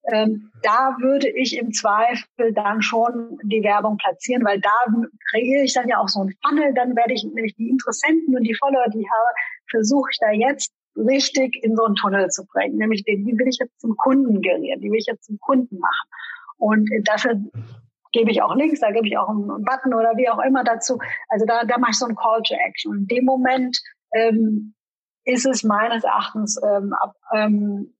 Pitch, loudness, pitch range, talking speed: 230 Hz, -20 LUFS, 215-260 Hz, 210 wpm